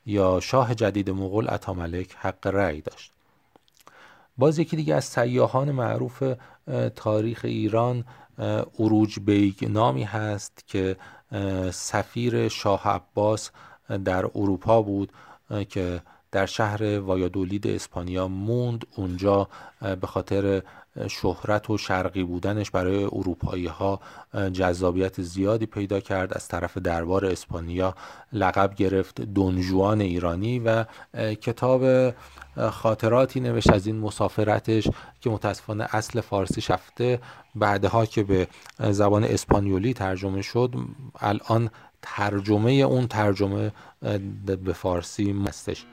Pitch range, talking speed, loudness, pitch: 95-115 Hz, 105 wpm, -25 LUFS, 100 Hz